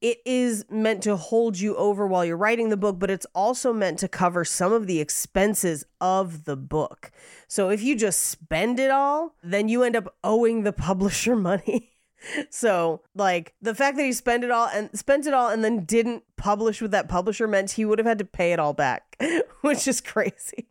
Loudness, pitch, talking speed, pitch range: -24 LUFS, 215 Hz, 210 wpm, 190-240 Hz